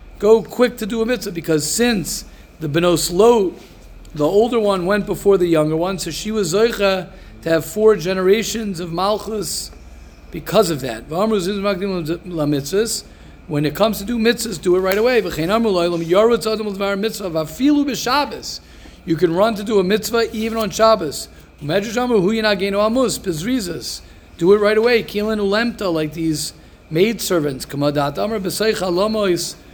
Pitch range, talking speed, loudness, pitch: 165-220 Hz, 120 wpm, -18 LUFS, 200 Hz